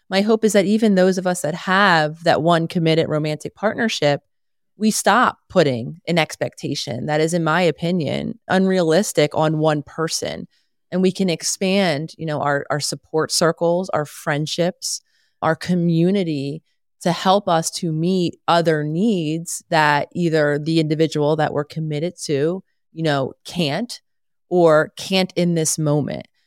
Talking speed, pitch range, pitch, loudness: 150 wpm, 155-185 Hz, 165 Hz, -19 LUFS